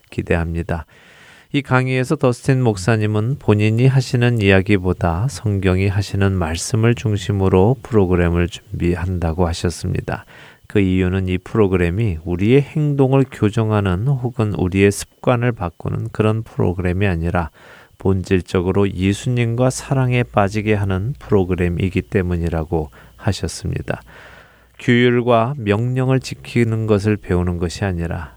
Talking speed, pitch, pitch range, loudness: 315 characters per minute, 105 Hz, 90-120 Hz, -18 LUFS